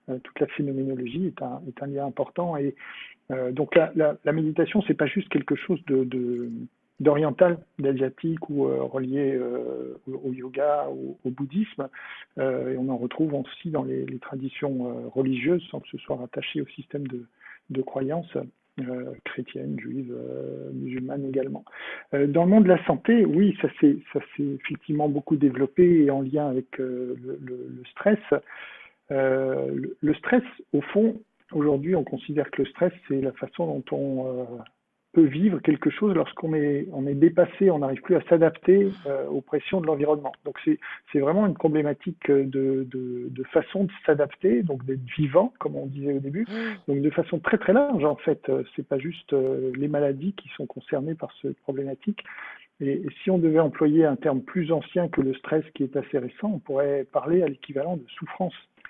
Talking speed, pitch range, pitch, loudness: 190 wpm, 135-170 Hz, 145 Hz, -25 LUFS